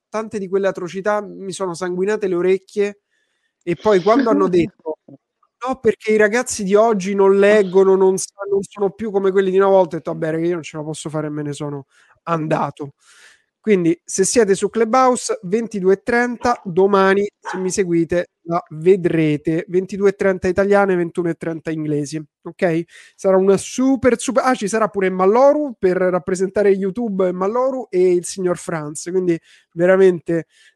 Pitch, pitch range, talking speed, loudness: 190 Hz, 175-205 Hz, 160 wpm, -18 LUFS